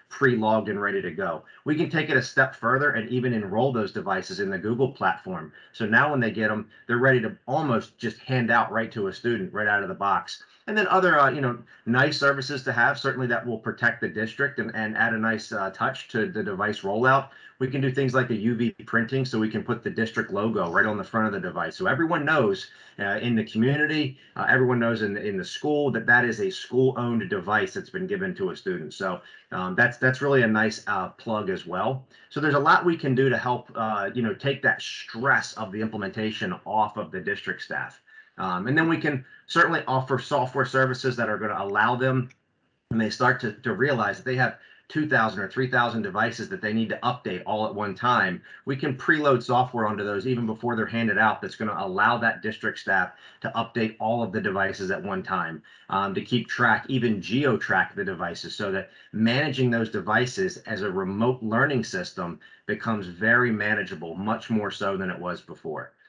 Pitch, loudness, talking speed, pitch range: 125 Hz, -25 LUFS, 225 wpm, 110-140 Hz